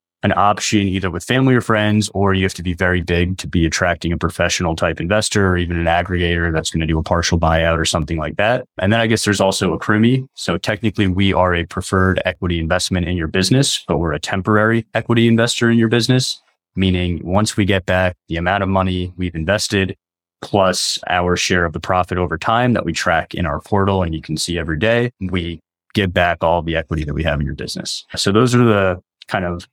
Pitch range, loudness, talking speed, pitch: 85-105 Hz, -17 LUFS, 230 wpm, 90 Hz